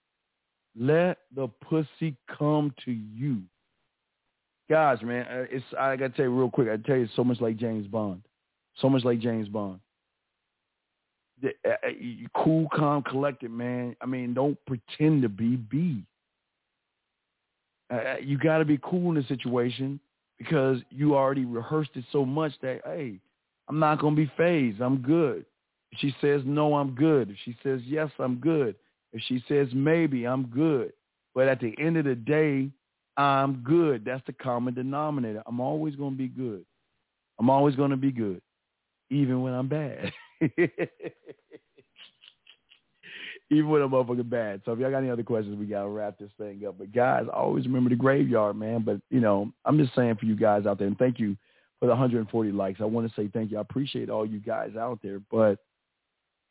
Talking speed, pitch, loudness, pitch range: 175 wpm, 130 Hz, -27 LUFS, 115-145 Hz